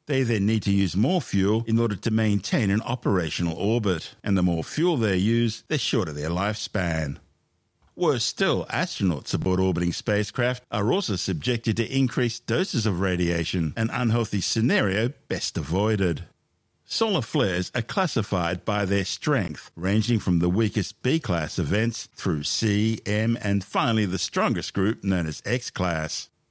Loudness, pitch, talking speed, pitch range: -25 LUFS, 105 Hz, 155 wpm, 90-115 Hz